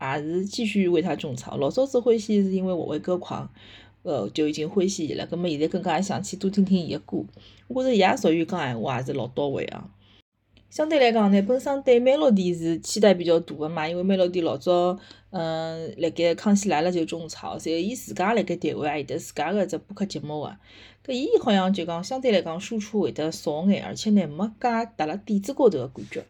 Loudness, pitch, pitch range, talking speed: -24 LUFS, 180 Hz, 160-210 Hz, 340 characters per minute